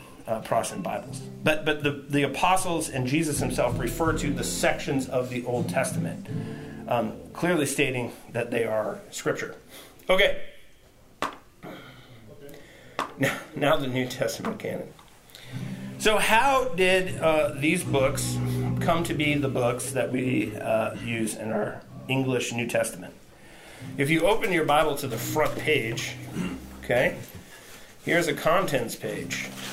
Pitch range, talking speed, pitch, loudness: 115-150 Hz, 135 wpm, 130 Hz, -26 LUFS